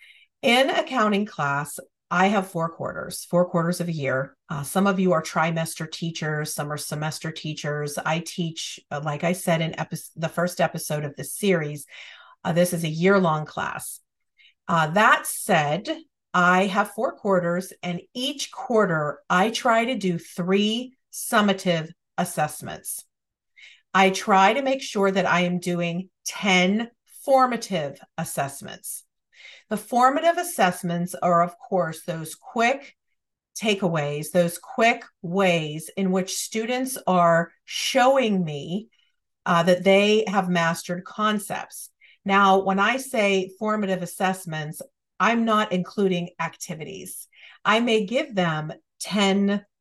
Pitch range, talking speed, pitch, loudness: 165-210 Hz, 135 wpm, 185 Hz, -23 LUFS